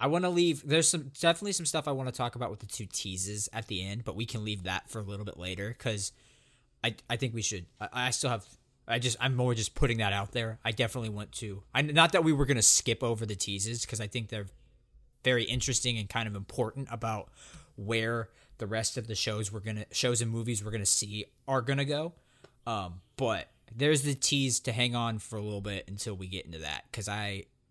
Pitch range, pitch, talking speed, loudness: 105-130 Hz, 115 Hz, 240 wpm, -31 LUFS